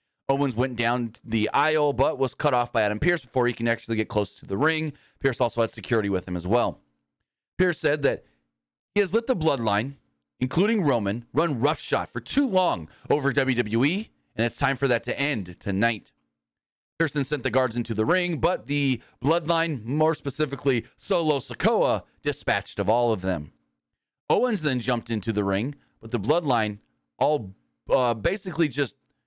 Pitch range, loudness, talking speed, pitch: 115-150 Hz, -25 LUFS, 175 wpm, 130 Hz